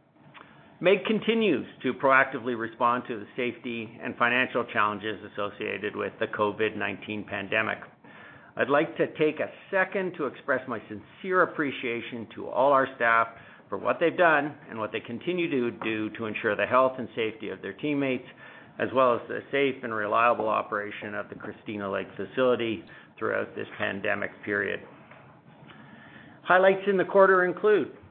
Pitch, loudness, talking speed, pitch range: 120 Hz, -27 LUFS, 155 wpm, 110-145 Hz